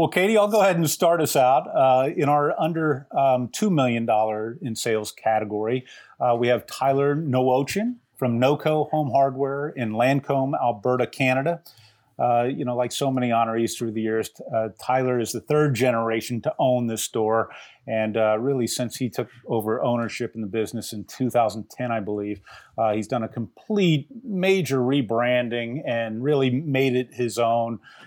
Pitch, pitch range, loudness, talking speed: 125 Hz, 115-140 Hz, -23 LUFS, 170 wpm